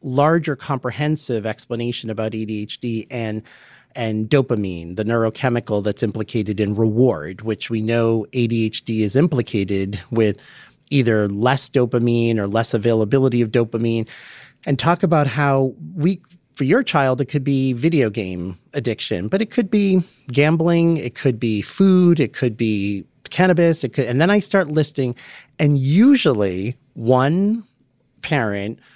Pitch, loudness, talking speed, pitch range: 125 Hz, -19 LUFS, 140 wpm, 110-145 Hz